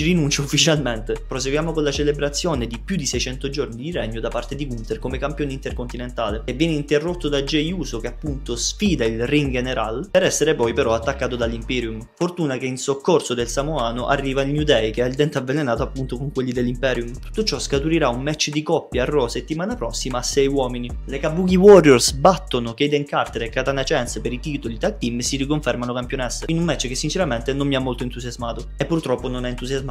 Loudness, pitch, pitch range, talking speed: -21 LUFS, 135 Hz, 120-150 Hz, 210 wpm